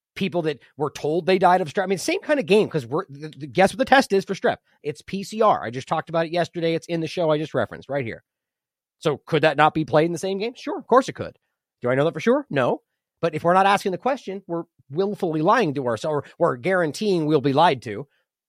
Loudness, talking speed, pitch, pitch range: -22 LUFS, 265 wpm, 170 Hz, 155-195 Hz